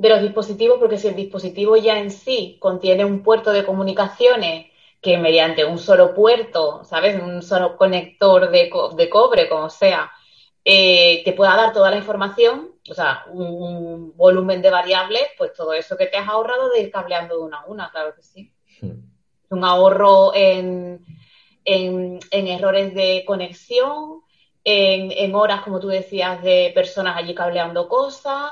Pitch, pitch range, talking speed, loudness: 195 Hz, 180-220 Hz, 170 wpm, -17 LUFS